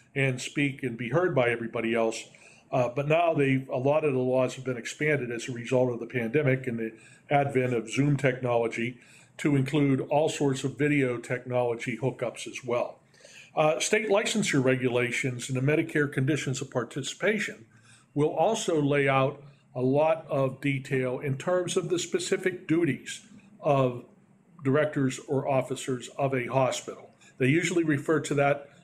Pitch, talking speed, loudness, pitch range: 135 Hz, 160 wpm, -27 LUFS, 125-155 Hz